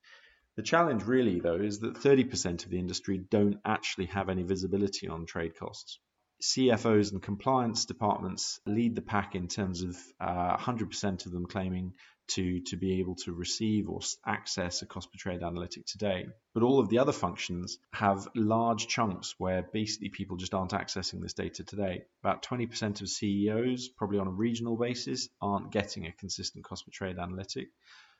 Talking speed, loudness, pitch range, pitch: 175 wpm, -32 LUFS, 90-115 Hz, 100 Hz